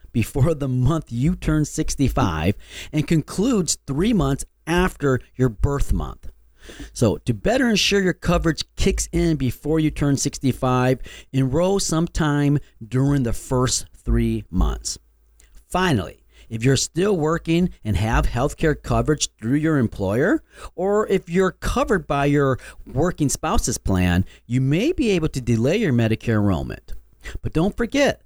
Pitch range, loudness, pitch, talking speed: 115-165 Hz, -21 LUFS, 140 Hz, 140 wpm